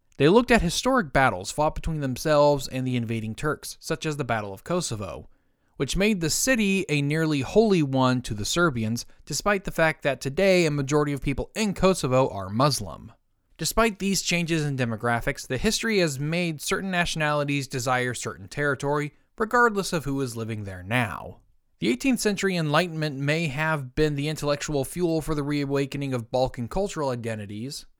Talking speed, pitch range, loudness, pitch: 170 wpm, 130-175 Hz, -25 LUFS, 145 Hz